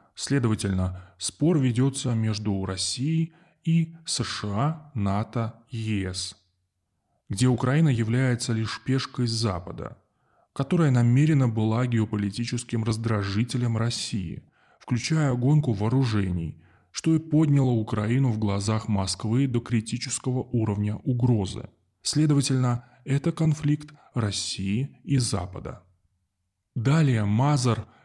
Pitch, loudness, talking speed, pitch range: 120 Hz, -25 LUFS, 90 wpm, 105-135 Hz